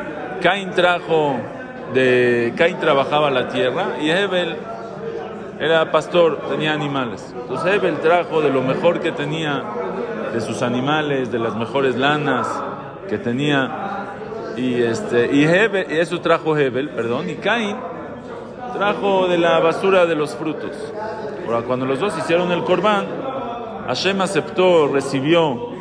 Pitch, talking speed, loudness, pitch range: 155 Hz, 130 wpm, -19 LUFS, 130-180 Hz